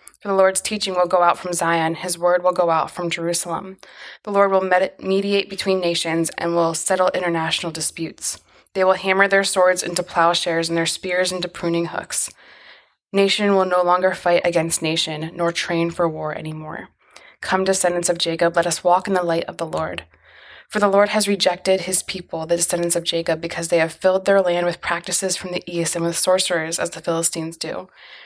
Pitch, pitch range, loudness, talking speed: 175 Hz, 165-185 Hz, -20 LUFS, 200 wpm